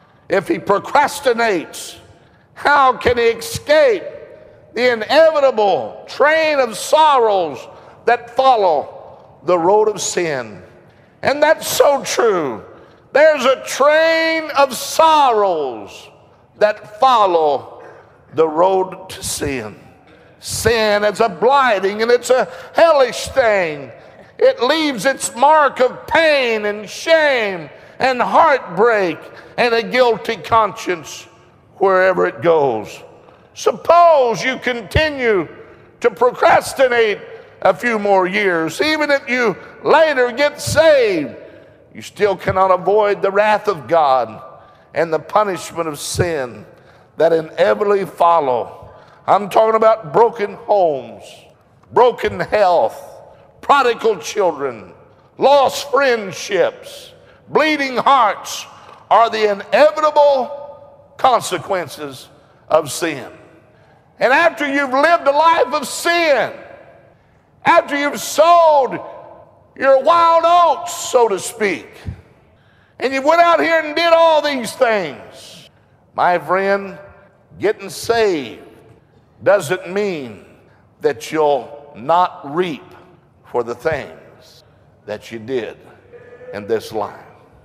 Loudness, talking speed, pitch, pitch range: -15 LUFS, 105 wpm, 245 Hz, 190-310 Hz